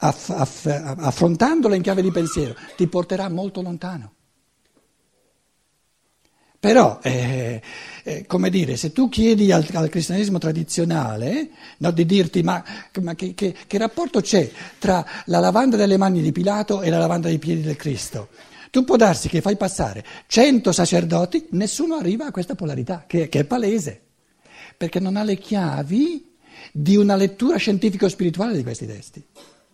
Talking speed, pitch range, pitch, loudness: 155 wpm, 160-205 Hz, 180 Hz, -20 LUFS